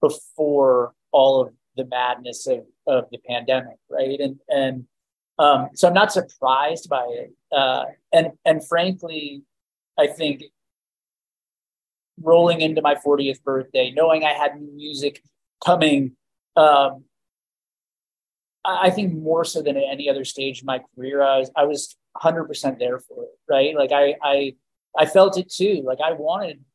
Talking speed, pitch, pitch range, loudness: 150 wpm, 145 Hz, 130-160 Hz, -20 LUFS